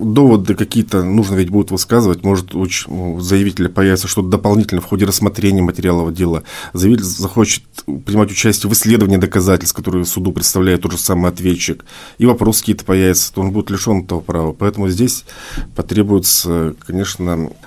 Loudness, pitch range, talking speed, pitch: -14 LUFS, 90-105 Hz, 155 wpm, 95 Hz